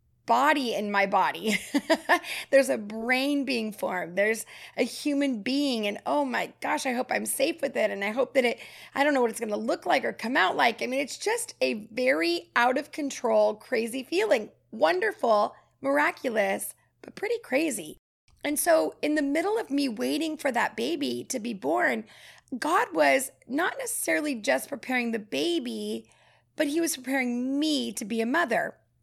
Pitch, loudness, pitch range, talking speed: 270 Hz, -27 LUFS, 230-305 Hz, 180 wpm